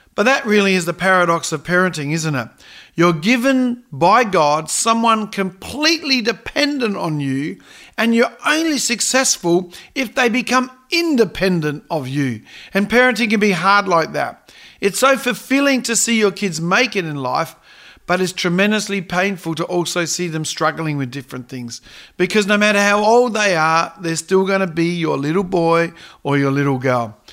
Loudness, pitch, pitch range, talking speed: -17 LUFS, 190 Hz, 165-230 Hz, 170 wpm